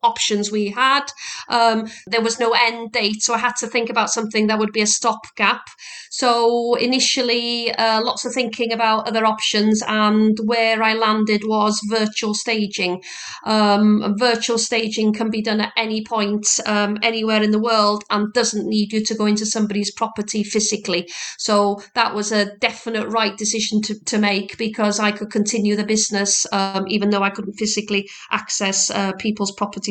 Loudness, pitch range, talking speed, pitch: -19 LUFS, 210-230 Hz, 175 wpm, 215 Hz